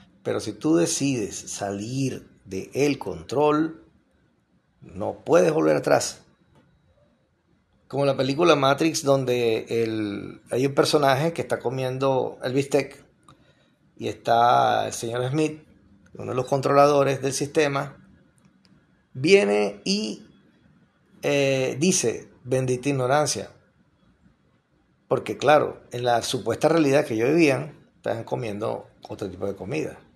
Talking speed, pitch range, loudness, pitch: 115 wpm, 115-145 Hz, -23 LUFS, 135 Hz